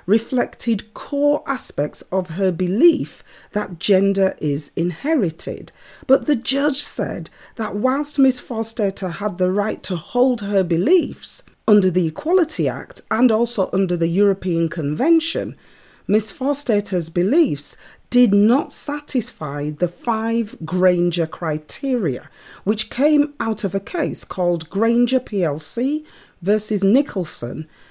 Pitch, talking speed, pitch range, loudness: 210 Hz, 120 wpm, 180-255 Hz, -20 LUFS